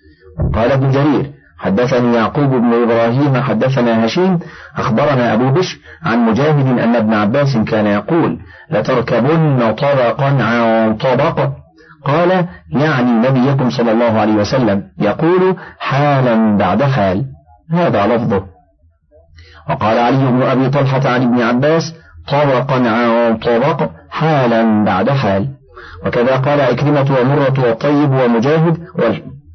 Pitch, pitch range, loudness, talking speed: 125 Hz, 110-140 Hz, -13 LUFS, 115 wpm